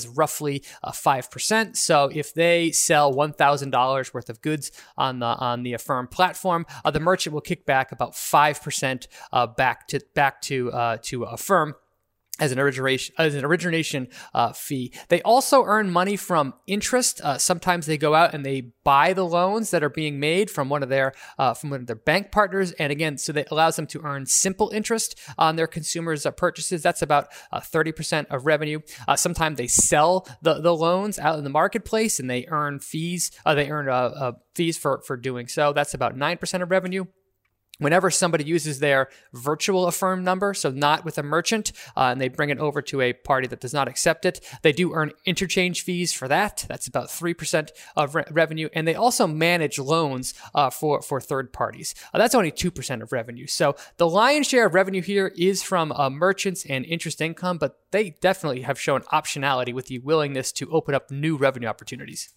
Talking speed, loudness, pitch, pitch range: 200 wpm, -23 LUFS, 155 Hz, 135-180 Hz